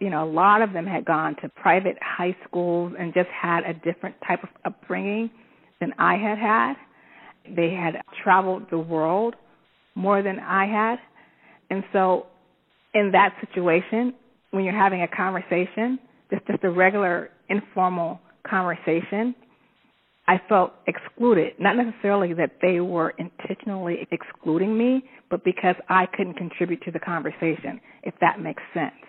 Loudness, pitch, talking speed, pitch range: -24 LUFS, 190 Hz, 150 wpm, 175-215 Hz